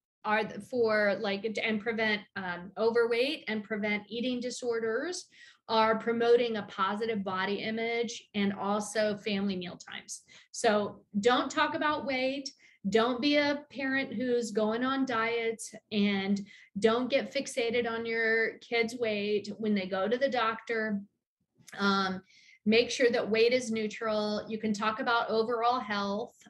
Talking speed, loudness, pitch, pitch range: 140 wpm, -30 LUFS, 225 Hz, 210-240 Hz